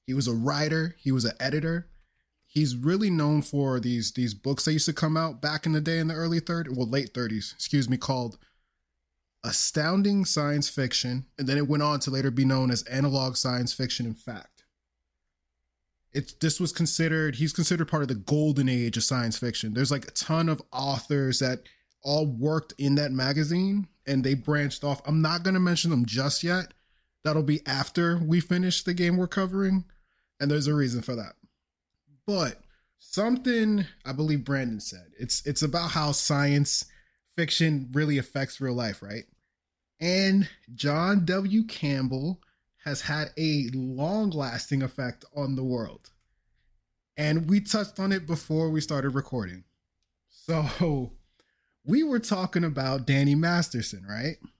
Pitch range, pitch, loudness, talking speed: 125-160 Hz, 145 Hz, -27 LUFS, 165 wpm